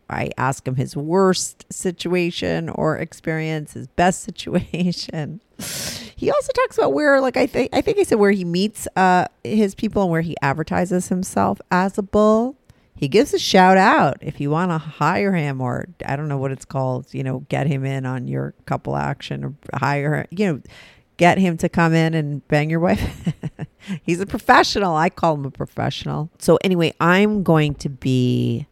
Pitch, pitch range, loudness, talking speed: 165 Hz, 140-190 Hz, -20 LUFS, 195 wpm